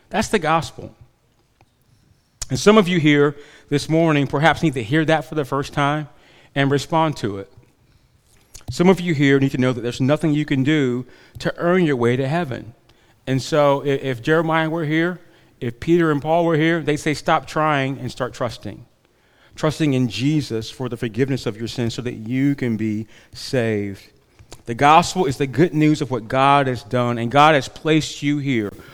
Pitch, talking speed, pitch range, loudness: 140 Hz, 195 wpm, 120-155 Hz, -19 LUFS